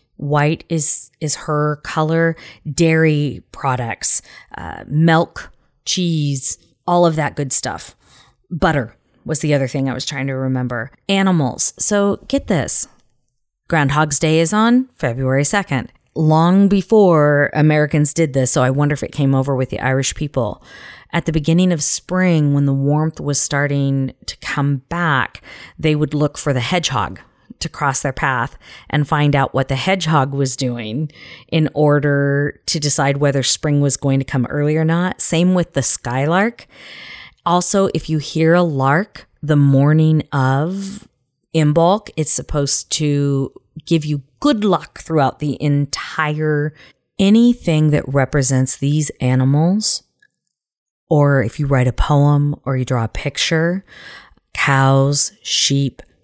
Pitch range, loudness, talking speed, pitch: 135-165 Hz, -16 LUFS, 145 wpm, 150 Hz